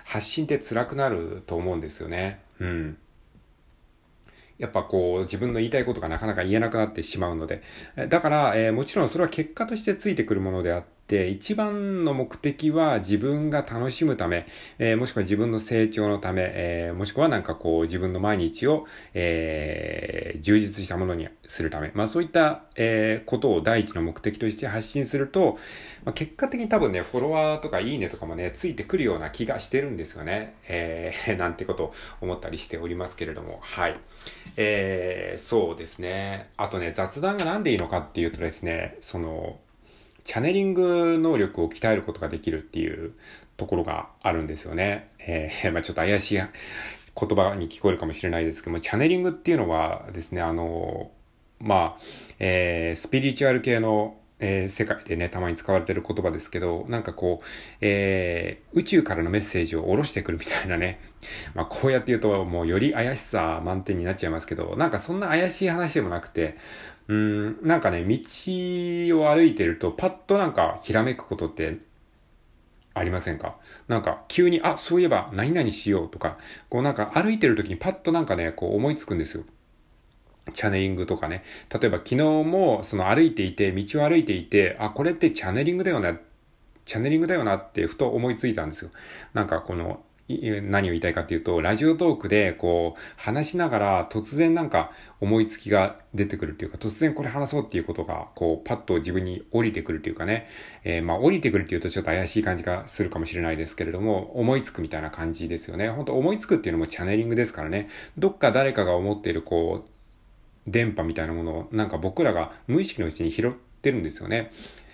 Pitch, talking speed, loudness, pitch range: 105 Hz, 405 characters per minute, -25 LUFS, 85-135 Hz